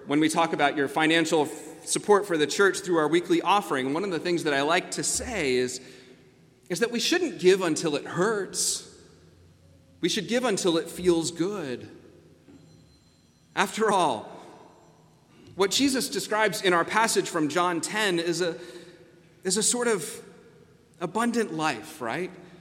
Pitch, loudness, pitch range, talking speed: 170 Hz, -25 LUFS, 150-195 Hz, 155 wpm